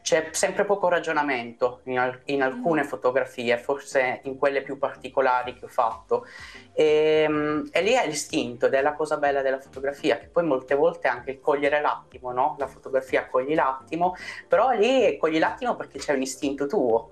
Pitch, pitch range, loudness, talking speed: 140 Hz, 130-160 Hz, -24 LUFS, 180 wpm